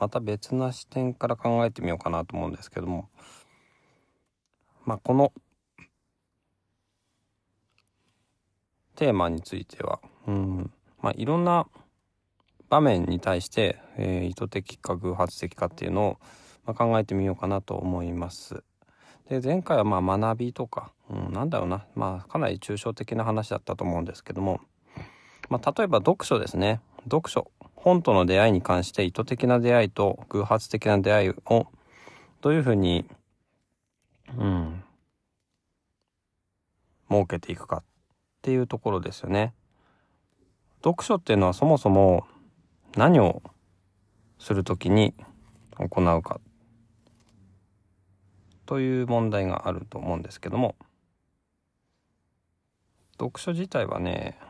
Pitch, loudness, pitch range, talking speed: 100 Hz, -26 LUFS, 90-115 Hz, 250 characters per minute